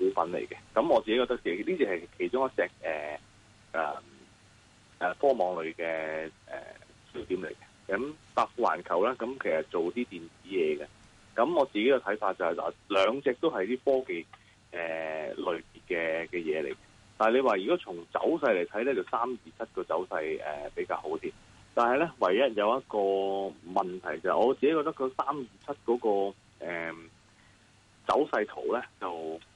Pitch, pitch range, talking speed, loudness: 105 Hz, 85-130 Hz, 250 characters per minute, -30 LUFS